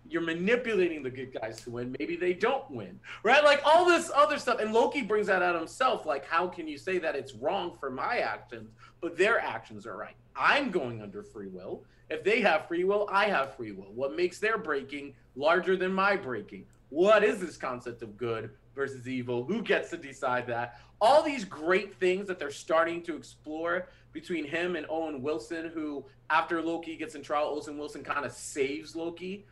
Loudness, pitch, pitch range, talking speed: -29 LUFS, 165 Hz, 135-205 Hz, 205 wpm